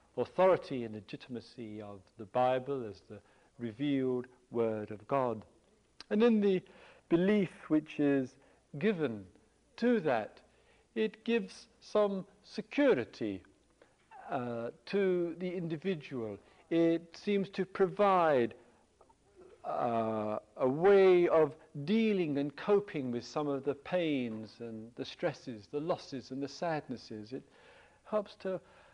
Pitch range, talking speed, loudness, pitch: 120-195 Hz, 115 wpm, -33 LUFS, 150 Hz